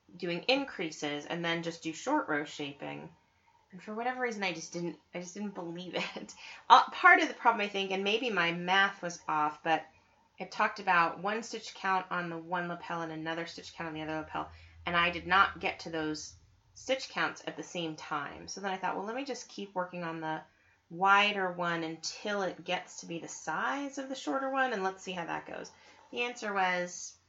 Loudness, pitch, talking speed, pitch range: -32 LUFS, 175 Hz, 220 wpm, 160-205 Hz